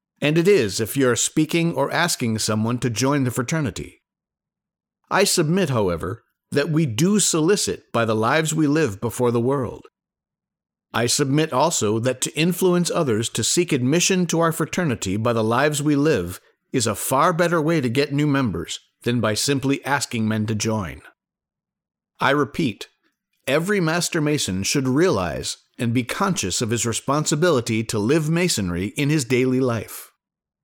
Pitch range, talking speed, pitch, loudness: 115-160 Hz, 165 wpm, 140 Hz, -21 LUFS